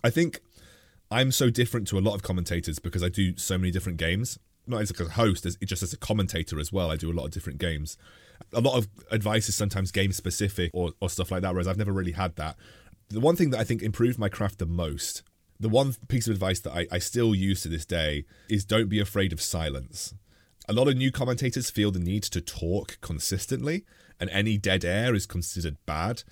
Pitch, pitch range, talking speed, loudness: 95 Hz, 90-110 Hz, 235 wpm, -28 LUFS